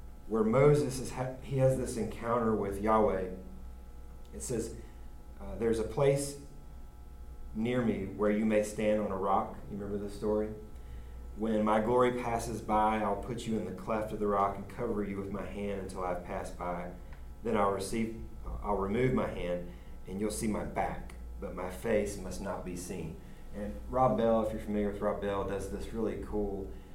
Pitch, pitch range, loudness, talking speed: 100 Hz, 90-110 Hz, -33 LUFS, 185 wpm